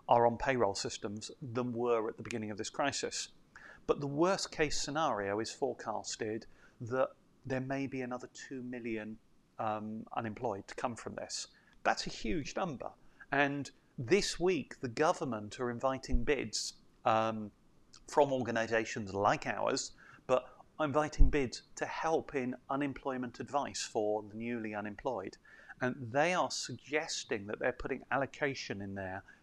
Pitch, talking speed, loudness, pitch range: 125 Hz, 145 wpm, -36 LUFS, 110-135 Hz